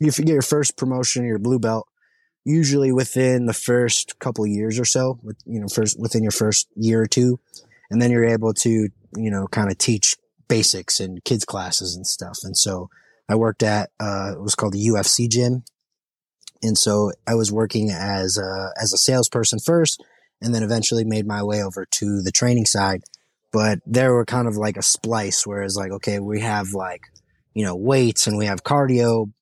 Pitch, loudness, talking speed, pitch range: 110 Hz, -20 LUFS, 200 wpm, 105-120 Hz